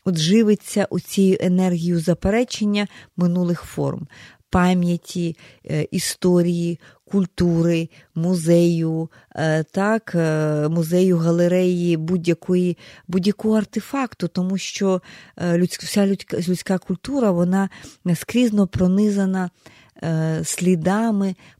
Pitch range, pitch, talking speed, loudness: 170-195 Hz, 180 Hz, 70 wpm, -20 LUFS